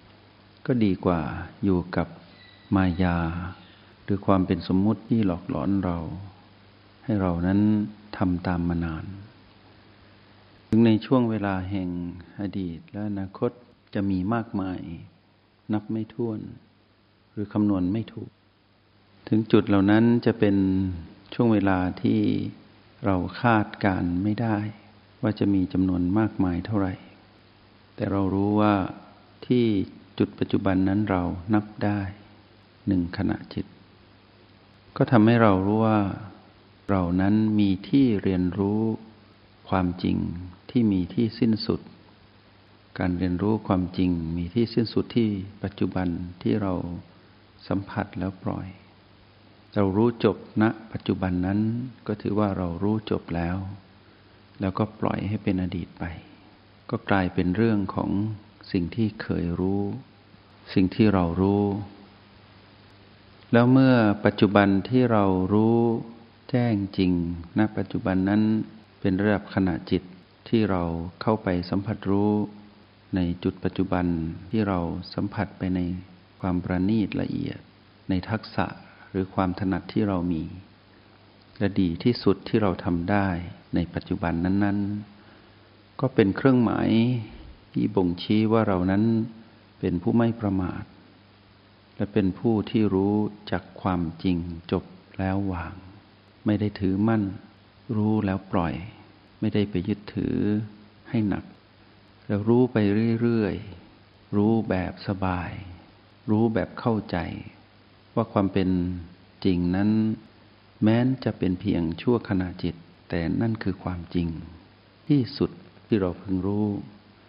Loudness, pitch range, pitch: -25 LUFS, 95-105 Hz, 100 Hz